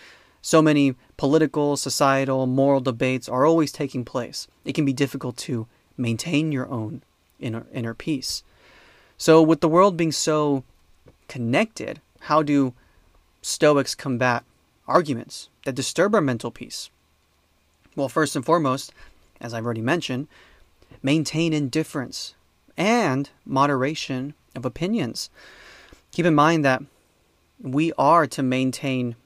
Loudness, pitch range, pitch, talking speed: -22 LUFS, 120-150 Hz, 135 Hz, 125 wpm